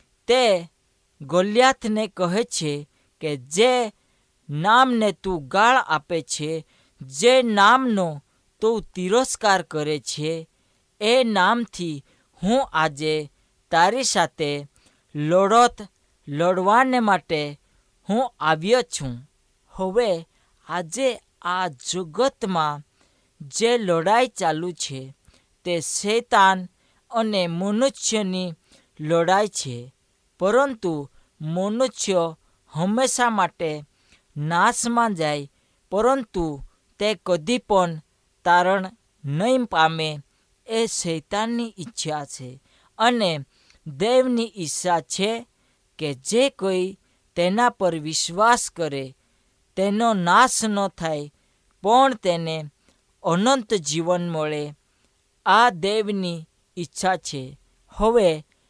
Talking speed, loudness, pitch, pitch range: 85 wpm, -22 LUFS, 180 Hz, 155-220 Hz